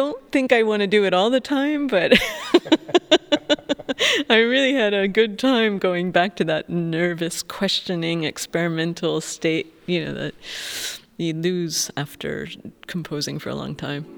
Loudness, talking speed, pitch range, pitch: -21 LUFS, 155 wpm, 170-260 Hz, 195 Hz